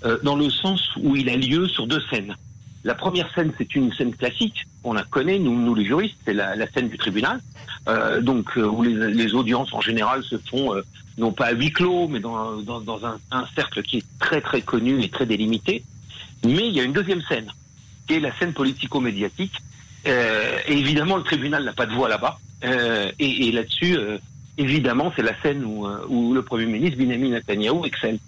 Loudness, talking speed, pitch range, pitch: -22 LUFS, 215 wpm, 115-145 Hz, 125 Hz